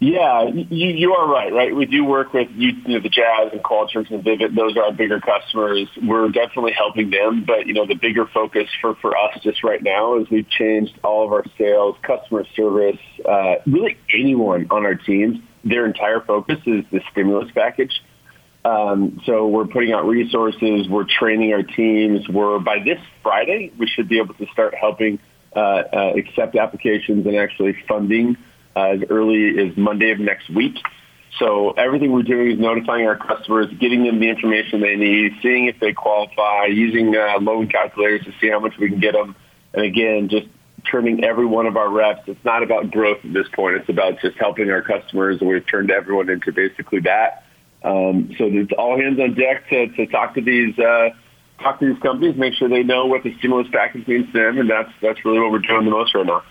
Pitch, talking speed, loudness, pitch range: 110 Hz, 205 wpm, -18 LUFS, 105-120 Hz